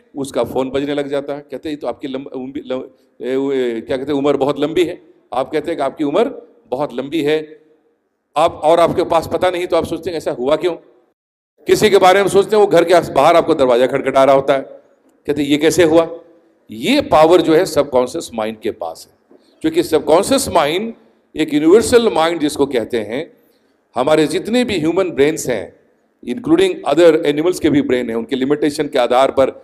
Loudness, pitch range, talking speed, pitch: -15 LUFS, 135-175 Hz, 200 wpm, 155 Hz